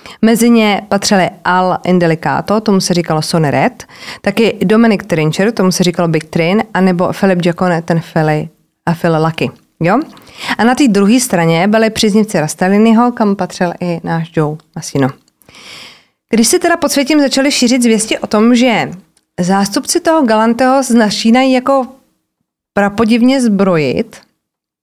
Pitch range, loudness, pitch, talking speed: 175-235 Hz, -12 LUFS, 200 Hz, 145 wpm